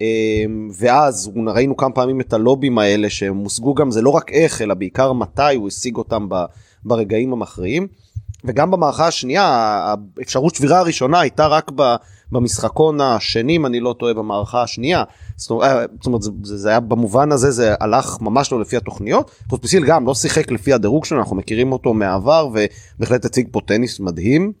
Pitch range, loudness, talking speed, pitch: 105-135 Hz, -17 LUFS, 165 wpm, 120 Hz